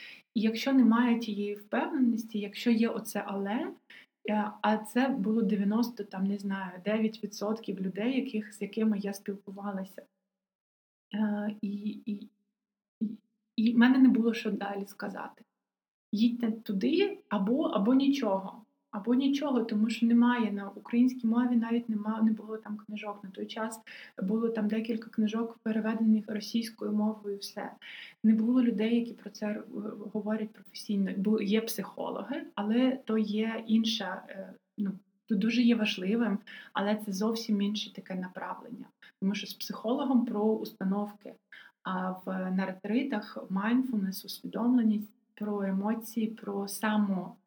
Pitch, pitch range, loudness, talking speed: 215 Hz, 205-230 Hz, -31 LUFS, 135 wpm